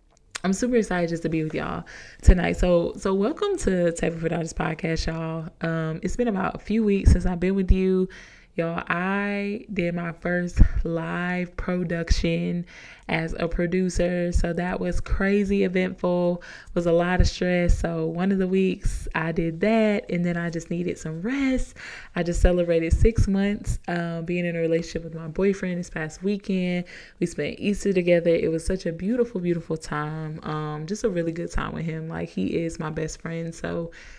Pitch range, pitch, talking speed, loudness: 165-190 Hz, 175 Hz, 190 wpm, -25 LUFS